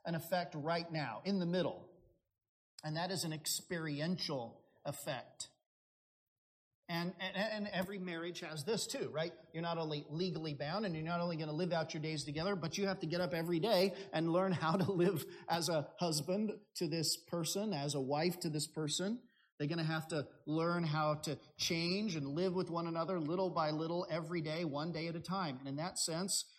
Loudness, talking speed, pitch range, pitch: -38 LUFS, 205 wpm, 155-180 Hz, 170 Hz